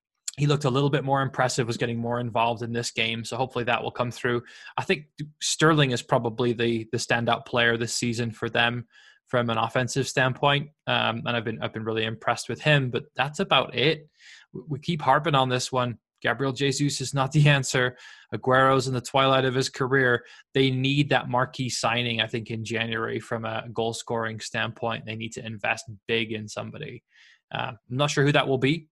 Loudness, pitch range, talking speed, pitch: -25 LUFS, 115-135 Hz, 205 wpm, 125 Hz